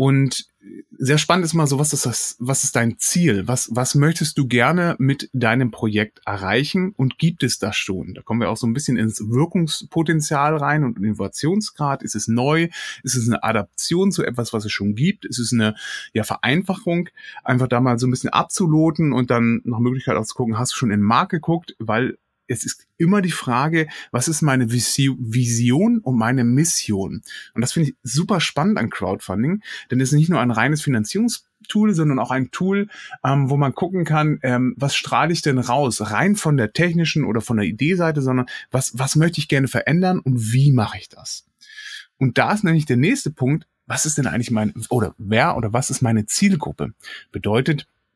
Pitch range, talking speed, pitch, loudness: 120-165 Hz, 200 wpm, 135 Hz, -20 LUFS